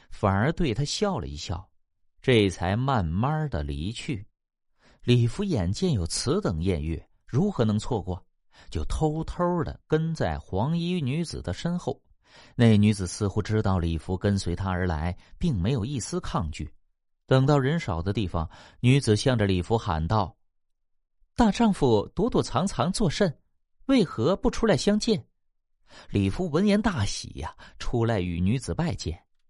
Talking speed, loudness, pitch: 220 characters per minute, -26 LUFS, 110 Hz